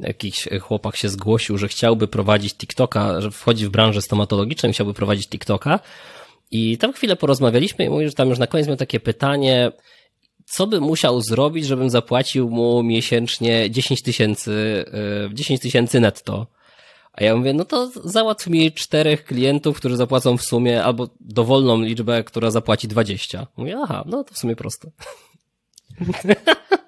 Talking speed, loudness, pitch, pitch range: 155 wpm, -19 LUFS, 120 Hz, 110-145 Hz